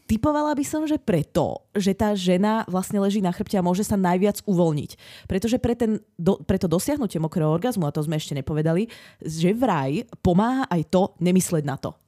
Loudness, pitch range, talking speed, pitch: -23 LUFS, 170-215 Hz, 180 wpm, 190 Hz